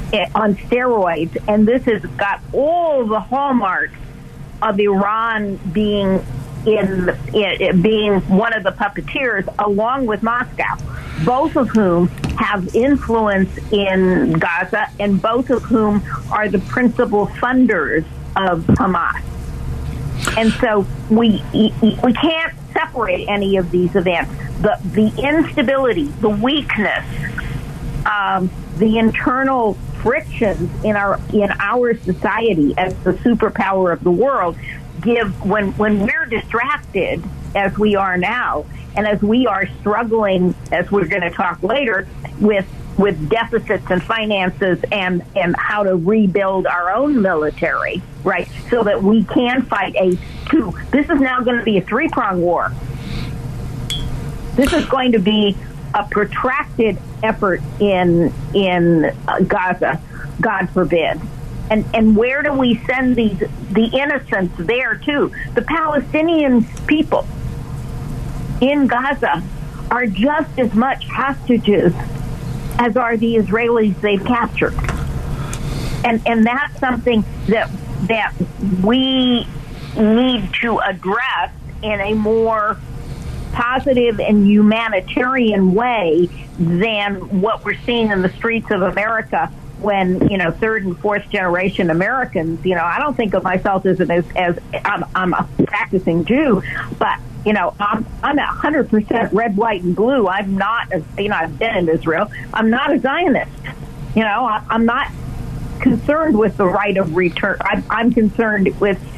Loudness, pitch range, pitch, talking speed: -17 LUFS, 185-235 Hz, 210 Hz, 135 wpm